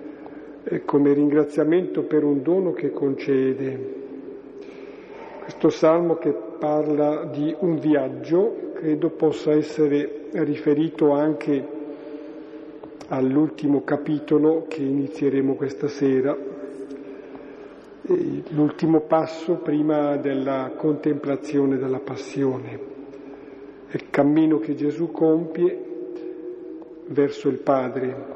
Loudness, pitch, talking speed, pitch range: -22 LUFS, 150 Hz, 85 wpm, 140-160 Hz